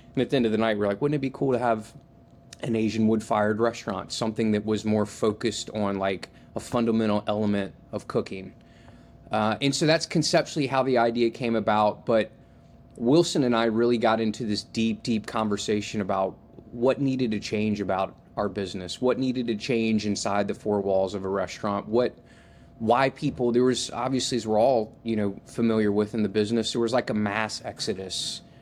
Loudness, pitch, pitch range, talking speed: -26 LUFS, 110 Hz, 105-120 Hz, 195 wpm